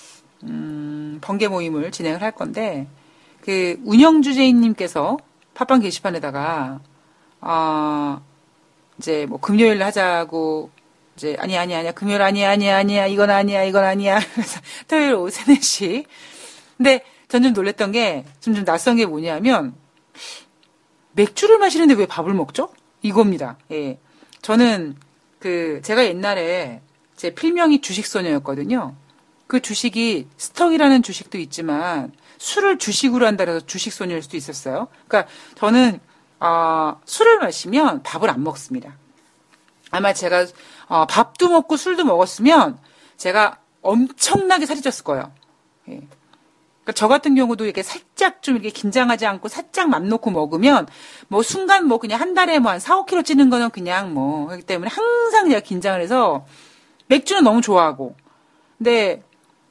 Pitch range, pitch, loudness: 165-260 Hz, 205 Hz, -18 LUFS